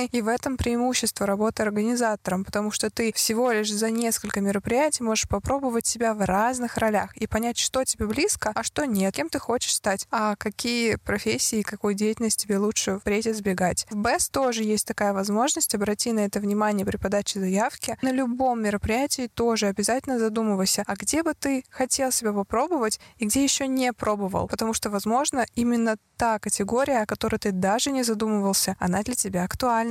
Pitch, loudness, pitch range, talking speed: 220 Hz, -24 LUFS, 205-240 Hz, 175 wpm